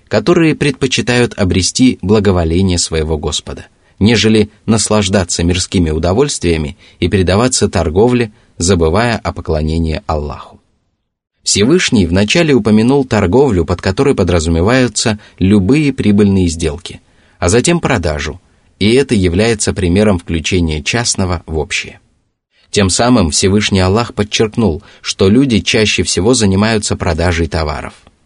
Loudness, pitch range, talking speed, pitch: -12 LUFS, 85-110 Hz, 105 wpm, 100 Hz